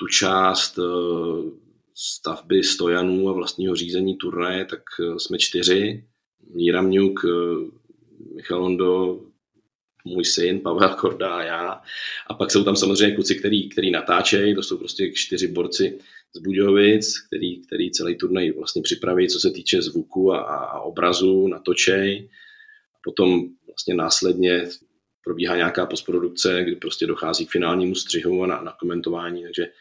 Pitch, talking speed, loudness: 95 Hz, 135 wpm, -21 LUFS